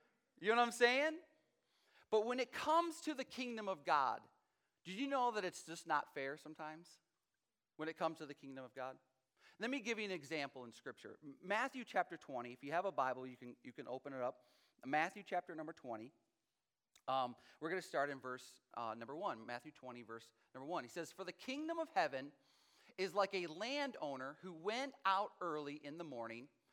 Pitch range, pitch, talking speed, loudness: 130-220 Hz, 165 Hz, 205 wpm, -42 LUFS